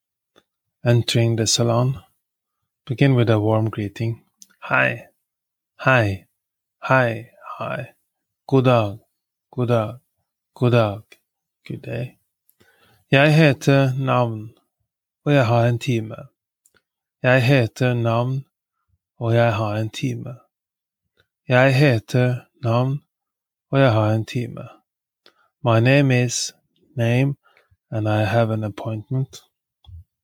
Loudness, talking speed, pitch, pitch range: -20 LUFS, 95 wpm, 120 Hz, 110-130 Hz